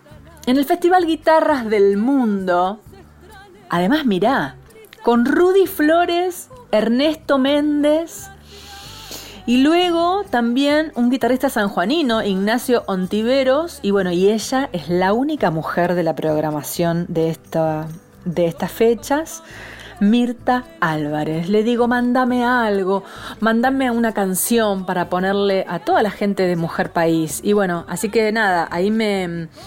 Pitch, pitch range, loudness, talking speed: 220 Hz, 180-265 Hz, -18 LUFS, 125 wpm